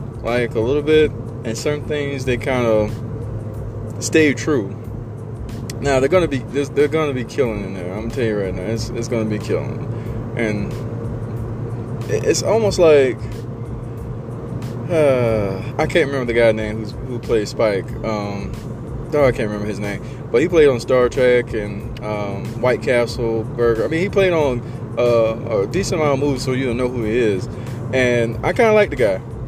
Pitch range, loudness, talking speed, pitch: 115-130 Hz, -19 LUFS, 185 wpm, 115 Hz